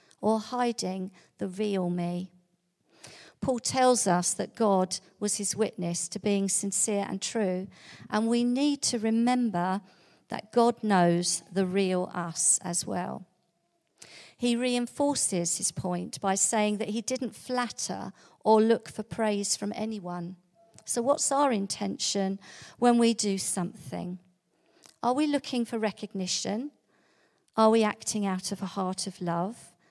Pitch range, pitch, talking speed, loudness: 180-230 Hz, 200 Hz, 140 wpm, -28 LUFS